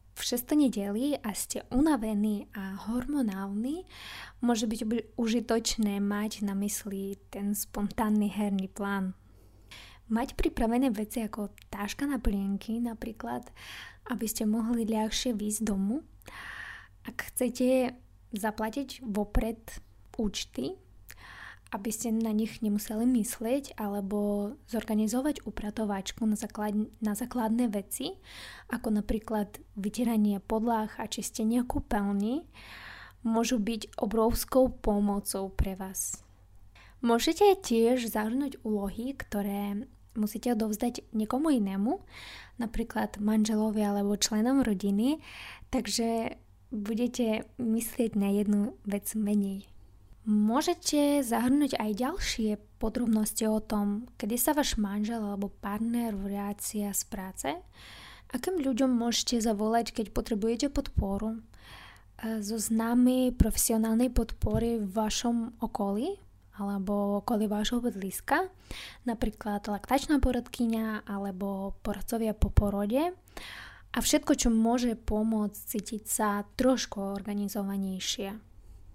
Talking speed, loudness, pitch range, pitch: 105 wpm, -30 LUFS, 205-240 Hz, 220 Hz